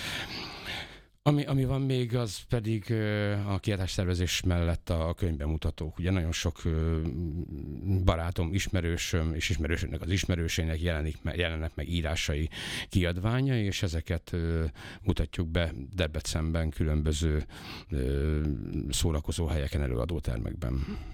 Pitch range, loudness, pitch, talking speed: 80-95 Hz, -31 LUFS, 85 Hz, 115 wpm